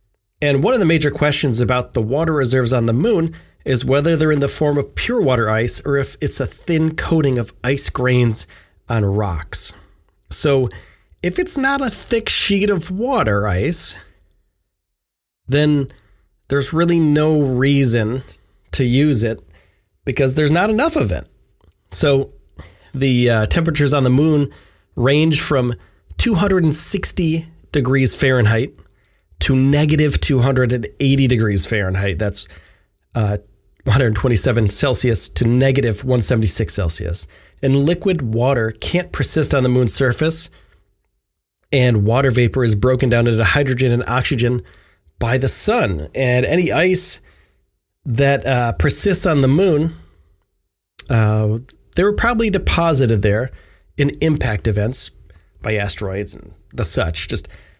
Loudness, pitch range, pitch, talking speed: -16 LUFS, 100-145 Hz, 125 Hz, 135 wpm